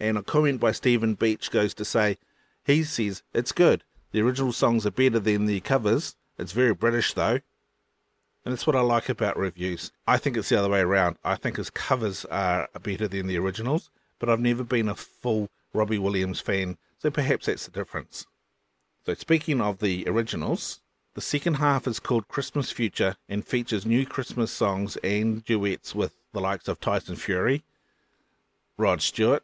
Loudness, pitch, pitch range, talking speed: -26 LUFS, 110 Hz, 100-125 Hz, 180 wpm